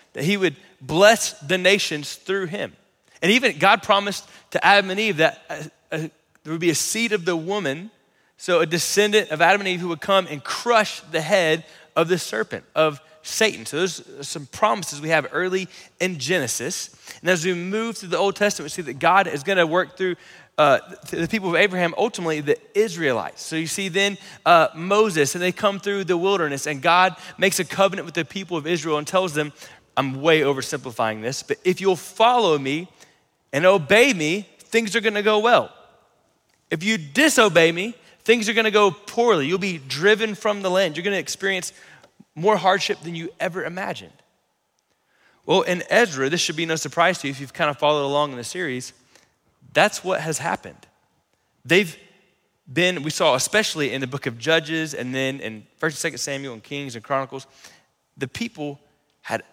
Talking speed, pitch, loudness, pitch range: 200 wpm, 180 Hz, -21 LUFS, 155-200 Hz